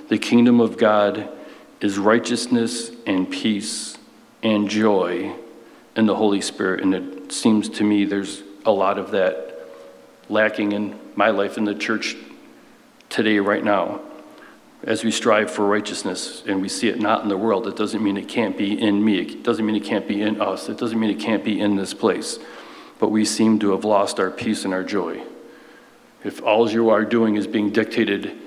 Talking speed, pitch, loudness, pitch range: 190 wpm, 105 Hz, -21 LUFS, 100-110 Hz